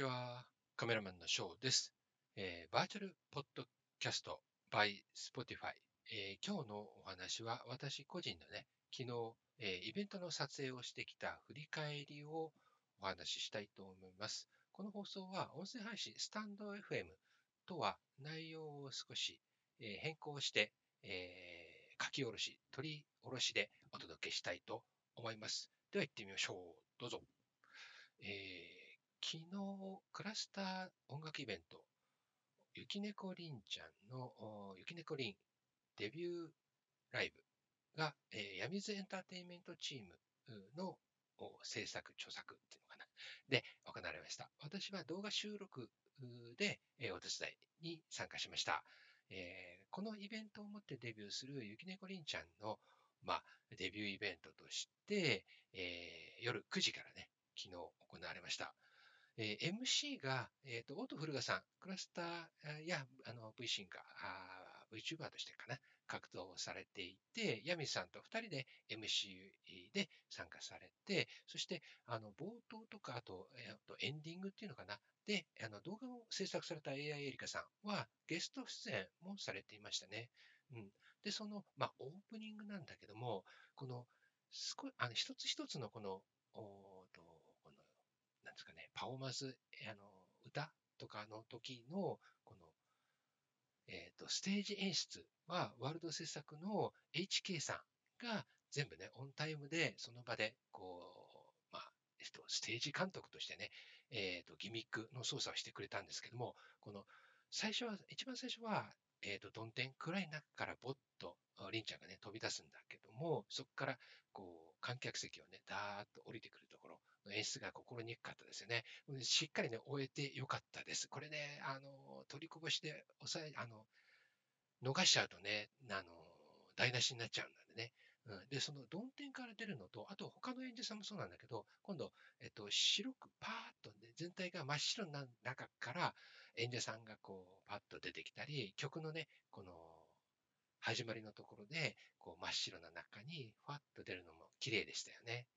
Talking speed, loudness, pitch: 315 characters per minute, -46 LUFS, 130 Hz